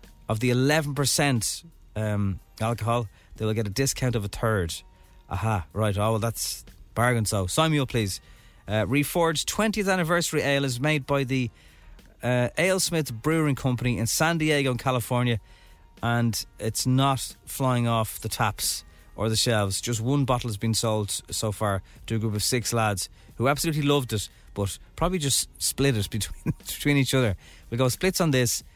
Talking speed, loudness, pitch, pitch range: 175 wpm, -25 LUFS, 115 Hz, 105-140 Hz